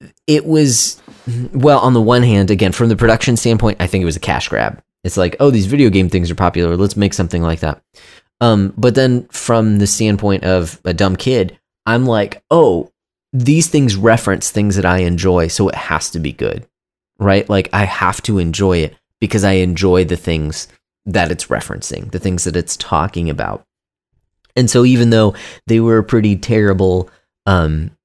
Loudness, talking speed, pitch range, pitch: -14 LUFS, 195 wpm, 90-115 Hz, 100 Hz